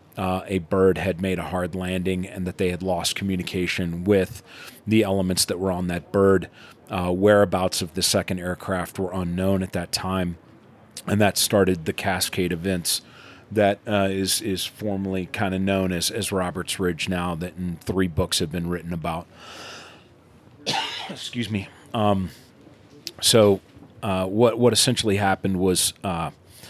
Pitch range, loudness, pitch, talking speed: 90-100 Hz, -23 LUFS, 95 Hz, 160 wpm